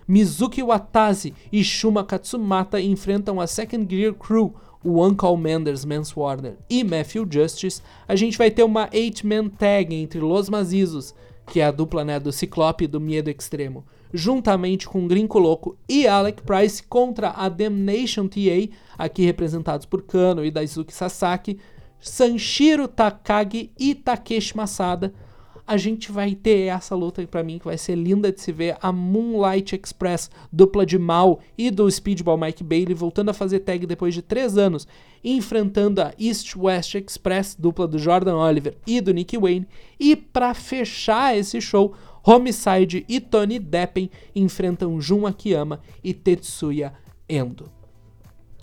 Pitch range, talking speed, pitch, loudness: 170-210 Hz, 155 wpm, 190 Hz, -21 LUFS